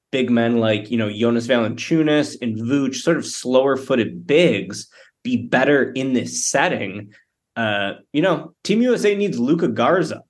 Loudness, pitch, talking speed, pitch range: -19 LUFS, 130 Hz, 155 wpm, 115-160 Hz